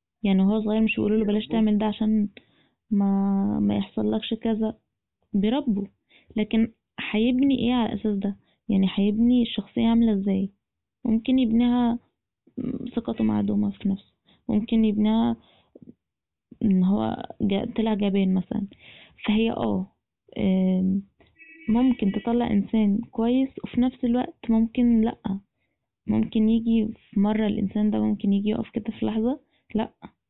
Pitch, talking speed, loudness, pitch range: 220 Hz, 130 wpm, -24 LUFS, 205-235 Hz